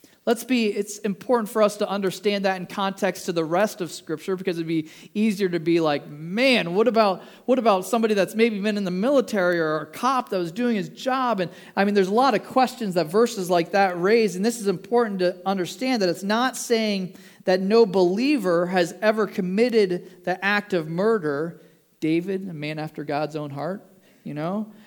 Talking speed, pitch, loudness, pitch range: 205 wpm, 195 Hz, -23 LUFS, 180-220 Hz